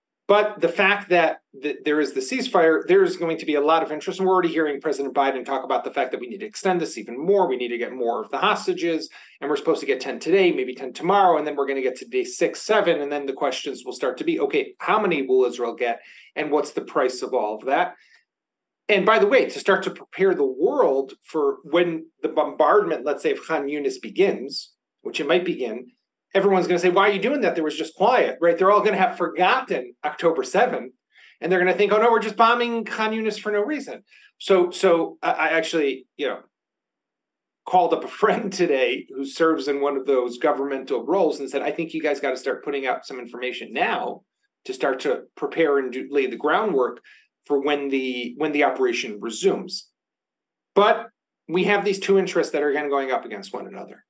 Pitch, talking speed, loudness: 180 Hz, 230 wpm, -22 LUFS